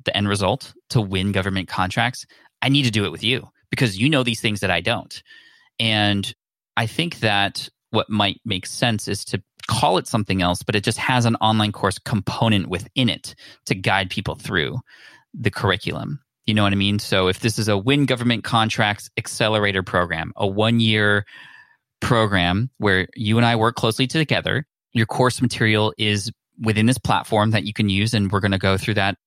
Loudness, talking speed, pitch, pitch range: -20 LUFS, 195 wpm, 110 Hz, 100-120 Hz